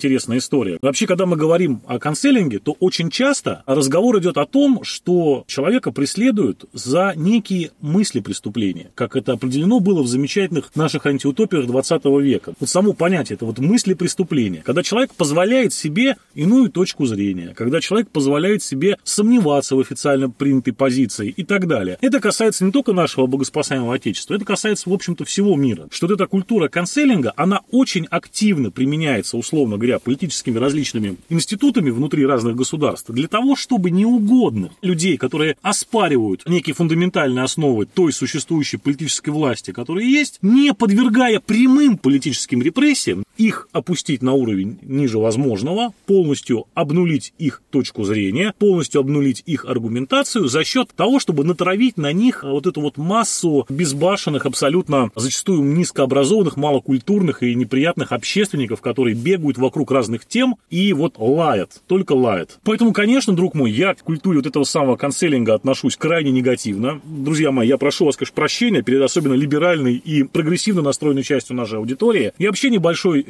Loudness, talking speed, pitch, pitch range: -18 LUFS, 150 wpm, 155 Hz, 135-200 Hz